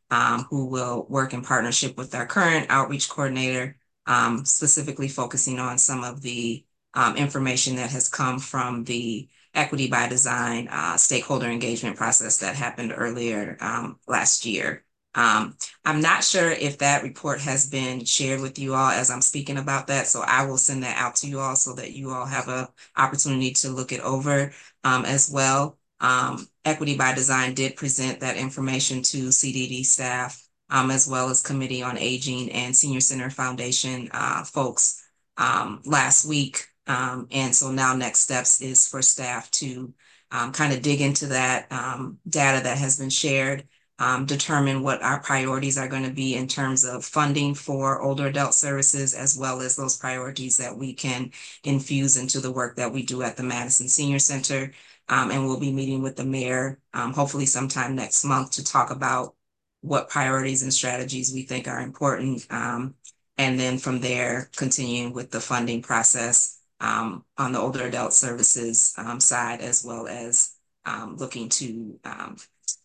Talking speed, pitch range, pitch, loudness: 175 wpm, 125-135 Hz, 130 Hz, -22 LUFS